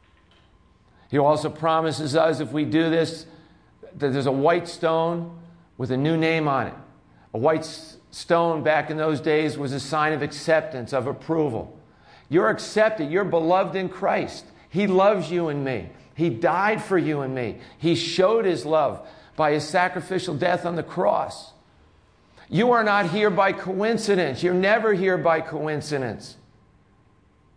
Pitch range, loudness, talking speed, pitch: 140-175 Hz, -23 LUFS, 155 wpm, 160 Hz